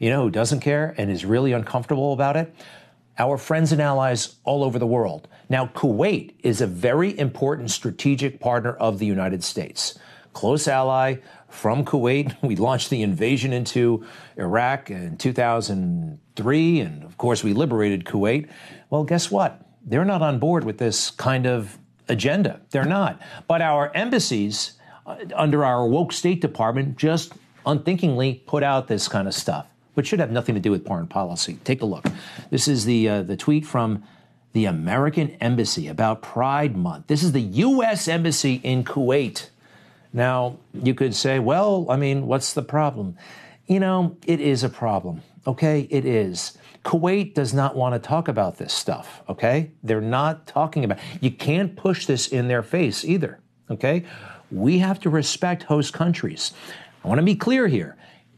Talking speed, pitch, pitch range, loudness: 170 wpm, 135 Hz, 120-160 Hz, -22 LUFS